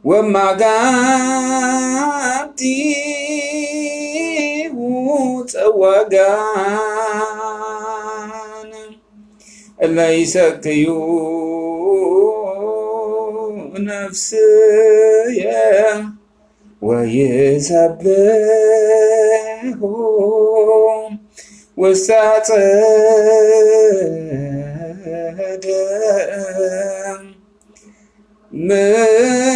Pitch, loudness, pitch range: 215 Hz, -14 LUFS, 195-225 Hz